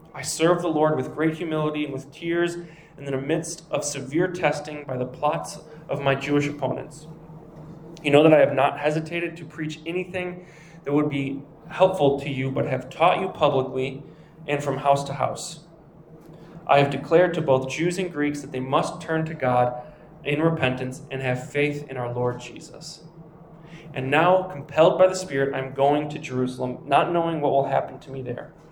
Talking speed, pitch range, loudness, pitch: 190 wpm, 140-165 Hz, -24 LUFS, 150 Hz